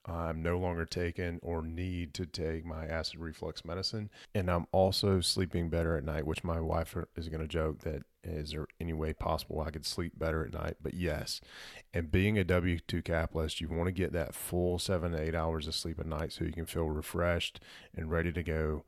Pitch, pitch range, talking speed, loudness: 85 Hz, 80-90 Hz, 220 wpm, -35 LUFS